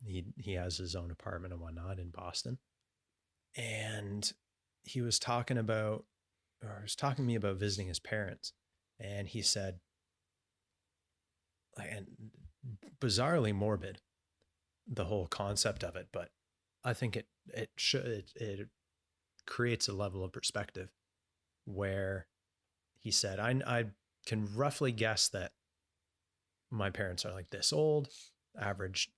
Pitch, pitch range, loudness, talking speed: 100 Hz, 90-110 Hz, -37 LUFS, 135 wpm